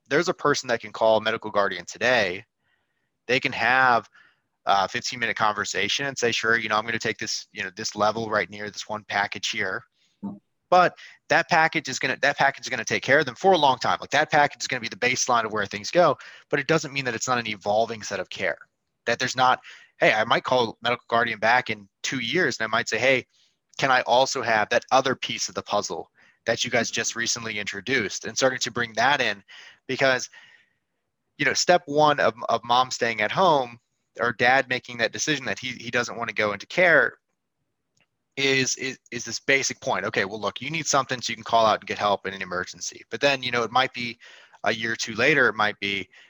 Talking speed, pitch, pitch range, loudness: 240 wpm, 120 Hz, 110-135 Hz, -23 LUFS